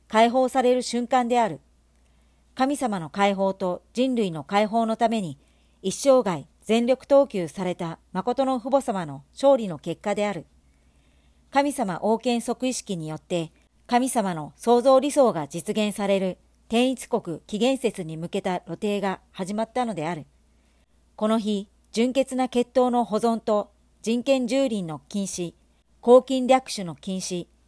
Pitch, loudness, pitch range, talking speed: 210 Hz, -24 LUFS, 175-245 Hz, 260 characters per minute